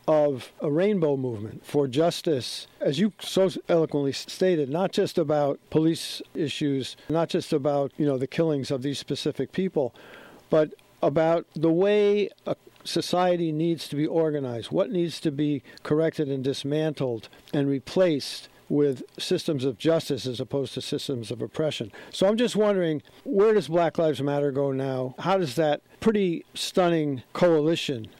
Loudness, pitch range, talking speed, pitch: -26 LUFS, 140-170 Hz, 155 wpm, 155 Hz